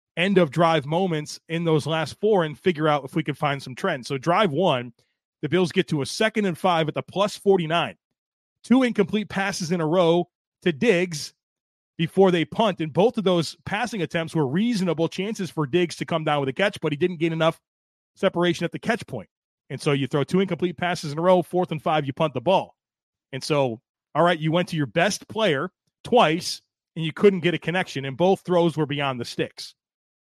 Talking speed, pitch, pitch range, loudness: 220 wpm, 170 Hz, 150-185 Hz, -23 LUFS